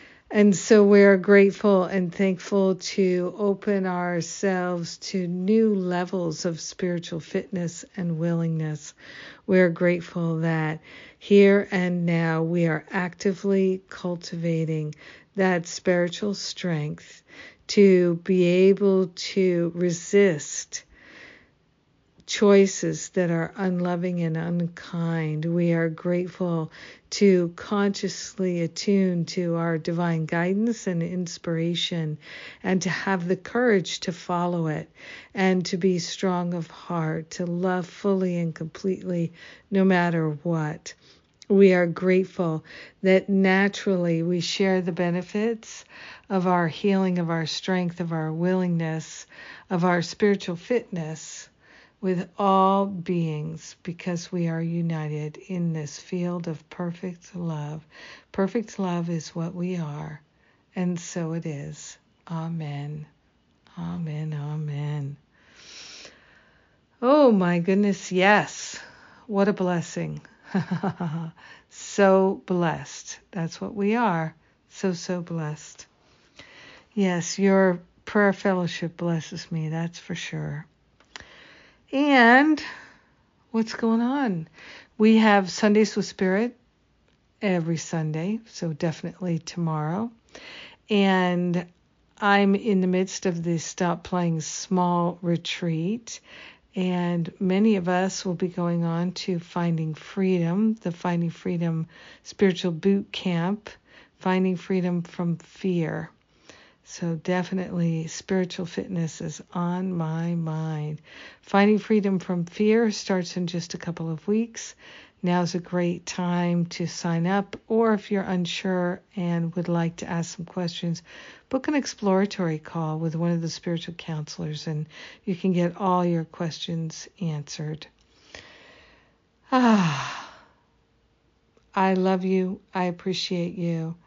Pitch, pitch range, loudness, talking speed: 180 Hz, 165-190 Hz, -25 LUFS, 115 wpm